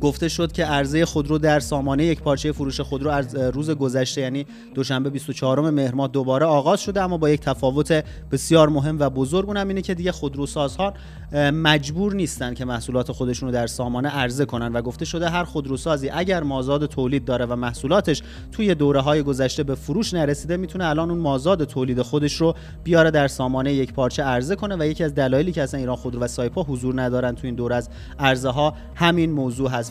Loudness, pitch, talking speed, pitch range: -22 LUFS, 145 Hz, 195 wpm, 130-160 Hz